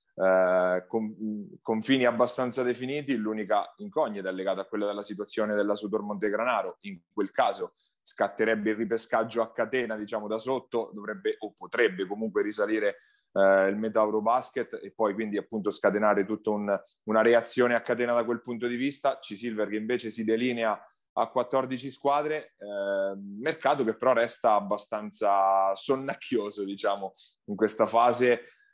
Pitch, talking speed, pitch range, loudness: 110 Hz, 150 wpm, 105-125 Hz, -28 LUFS